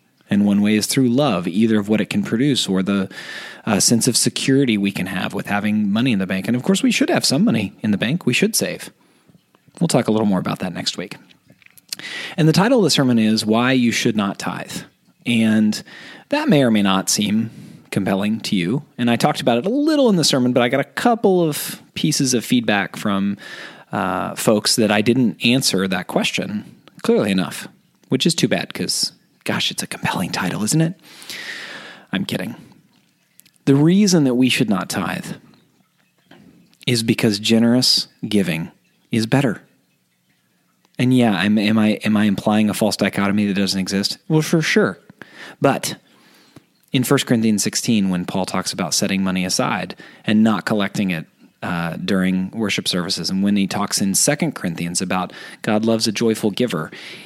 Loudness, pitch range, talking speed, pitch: -18 LUFS, 100-140 Hz, 190 wpm, 115 Hz